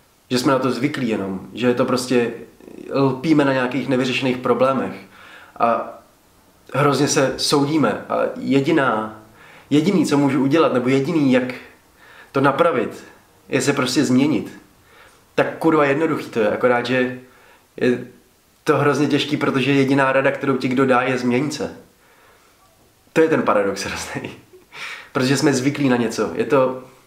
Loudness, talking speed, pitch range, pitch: -19 LUFS, 145 wpm, 125-145 Hz, 130 Hz